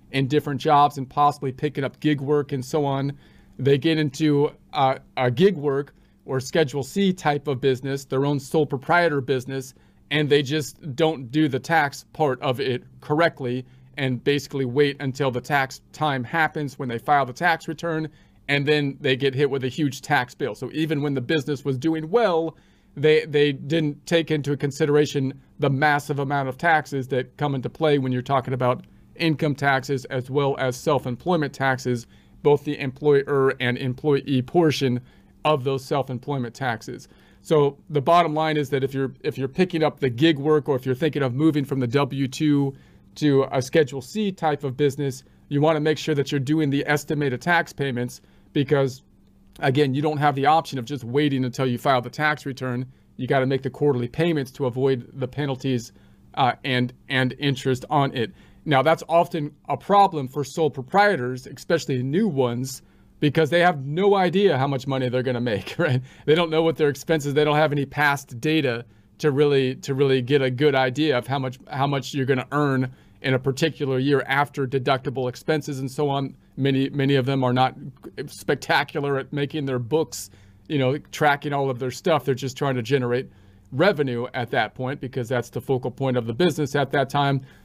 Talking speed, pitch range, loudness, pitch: 195 wpm, 130-150 Hz, -23 LUFS, 140 Hz